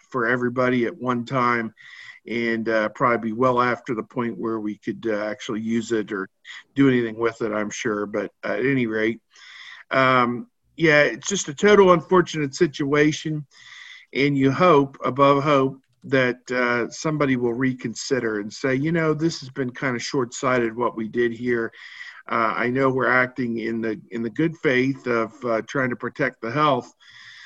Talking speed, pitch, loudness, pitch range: 180 wpm, 125 Hz, -22 LUFS, 115-140 Hz